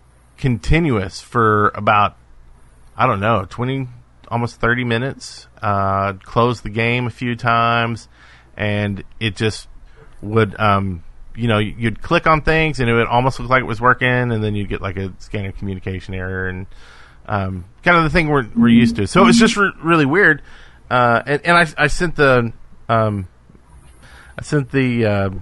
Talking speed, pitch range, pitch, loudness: 175 wpm, 95-125 Hz, 115 Hz, -17 LUFS